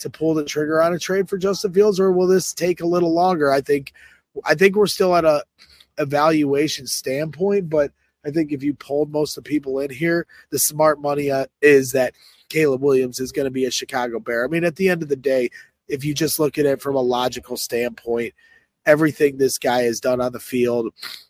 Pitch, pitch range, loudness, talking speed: 145 Hz, 135-170 Hz, -20 LUFS, 225 wpm